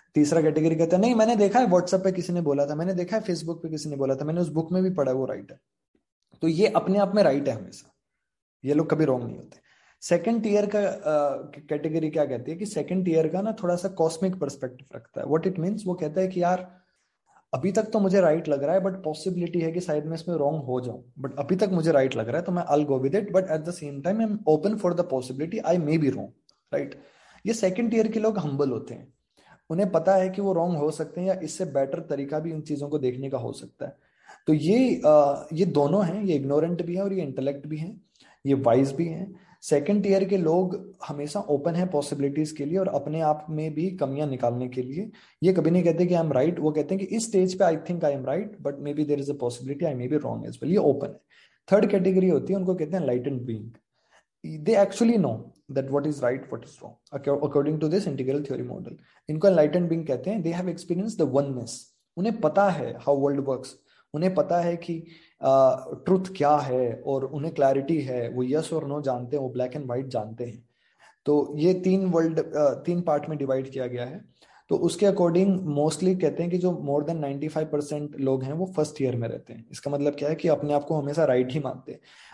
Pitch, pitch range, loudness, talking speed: 155 Hz, 140-185 Hz, -25 LUFS, 245 wpm